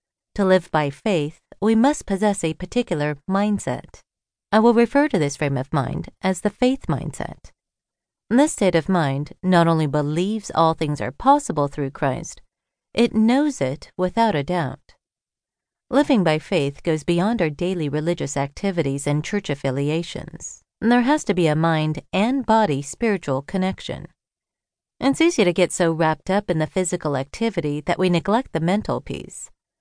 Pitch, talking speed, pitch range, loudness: 175 Hz, 160 wpm, 150-215 Hz, -21 LUFS